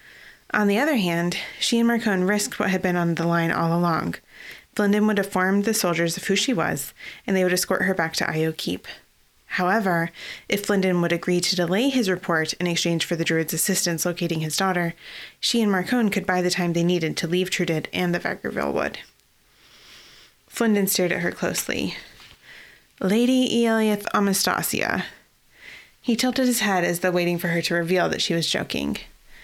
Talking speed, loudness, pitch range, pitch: 185 wpm, -23 LUFS, 170-210 Hz, 185 Hz